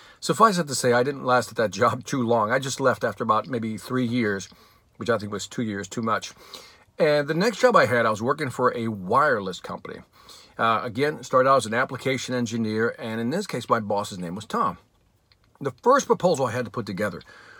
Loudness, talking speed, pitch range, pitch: -24 LUFS, 225 wpm, 110-135 Hz, 120 Hz